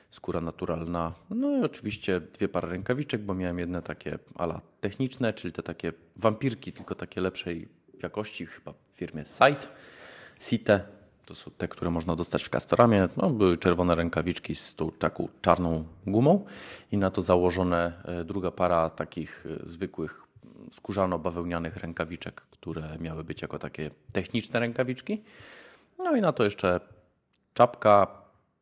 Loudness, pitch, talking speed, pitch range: -29 LUFS, 90 Hz, 140 wpm, 85-105 Hz